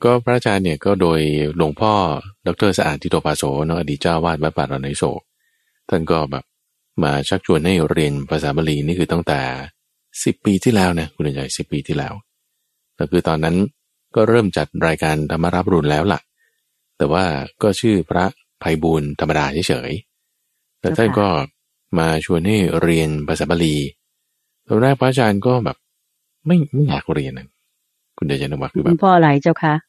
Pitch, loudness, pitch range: 85 Hz, -18 LUFS, 75-110 Hz